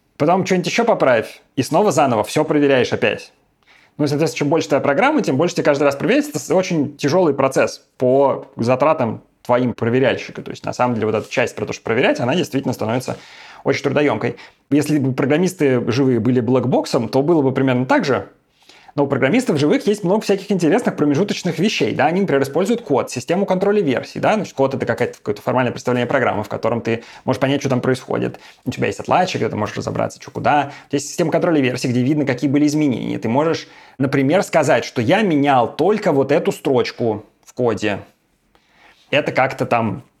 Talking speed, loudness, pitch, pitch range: 195 wpm, -18 LUFS, 140 Hz, 130-165 Hz